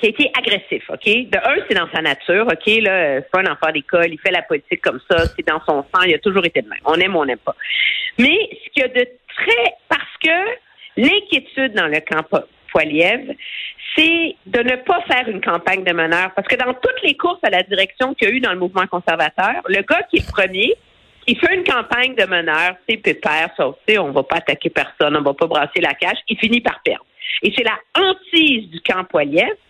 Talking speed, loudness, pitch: 245 wpm, -16 LUFS, 225 Hz